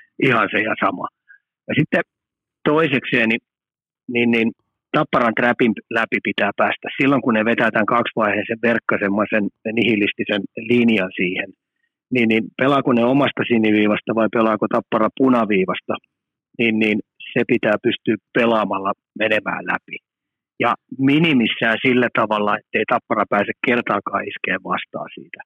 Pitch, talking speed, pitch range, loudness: 115 Hz, 125 wpm, 110-125 Hz, -19 LUFS